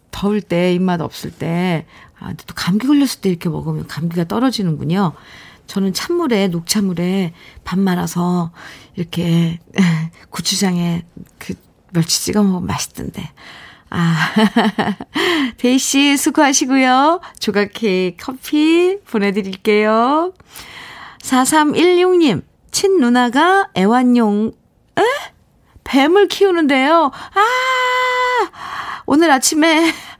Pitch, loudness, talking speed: 220 Hz, -15 LUFS, 220 characters per minute